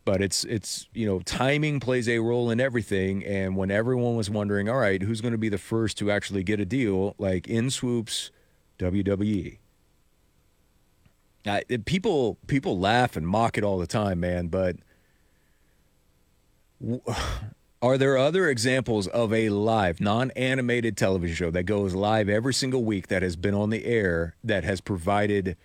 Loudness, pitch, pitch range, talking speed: -26 LUFS, 105 Hz, 95-115 Hz, 165 wpm